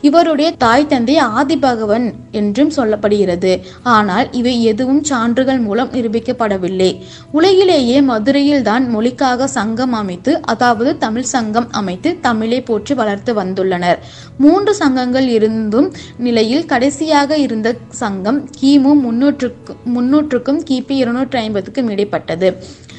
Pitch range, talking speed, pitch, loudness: 220-280 Hz, 105 wpm, 250 Hz, -14 LUFS